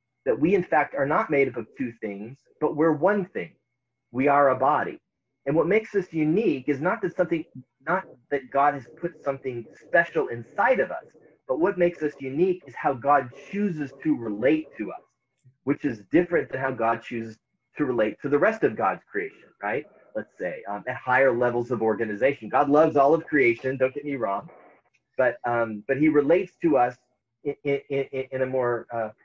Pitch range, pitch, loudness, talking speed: 125-155 Hz, 135 Hz, -25 LUFS, 200 wpm